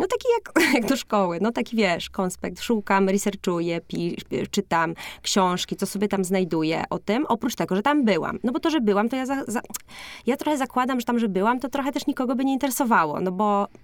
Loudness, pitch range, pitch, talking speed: -24 LUFS, 195-270 Hz, 225 Hz, 220 wpm